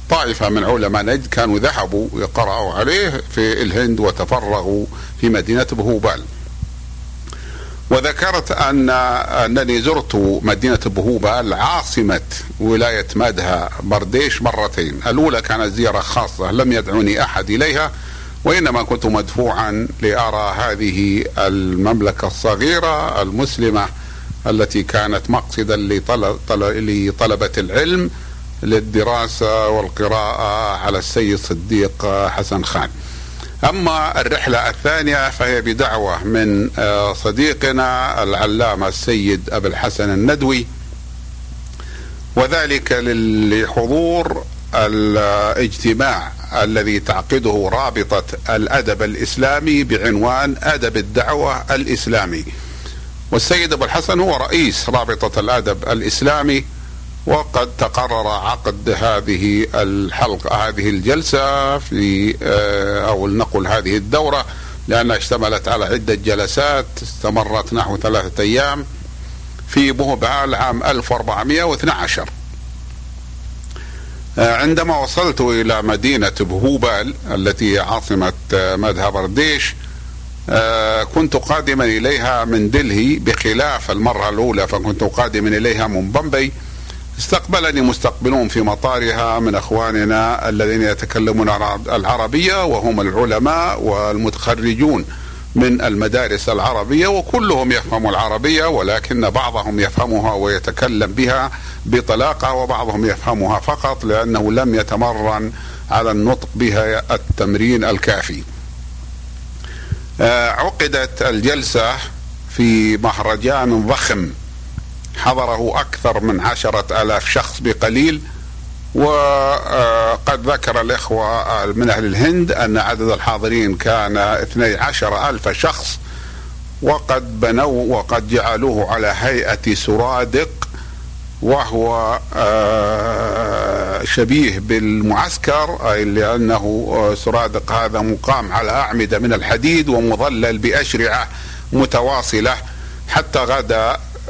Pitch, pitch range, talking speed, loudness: 110 Hz, 90-120 Hz, 90 wpm, -16 LUFS